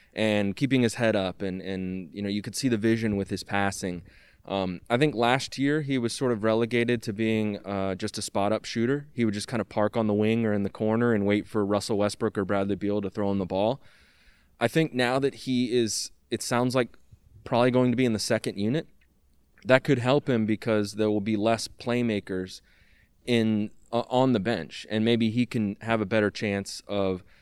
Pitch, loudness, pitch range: 110 Hz, -27 LUFS, 100-120 Hz